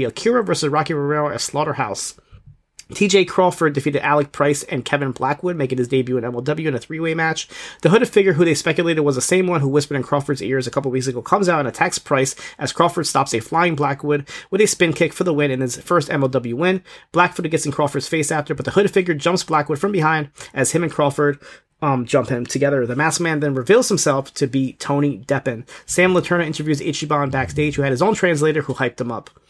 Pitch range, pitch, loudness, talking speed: 135-170 Hz, 150 Hz, -19 LUFS, 230 wpm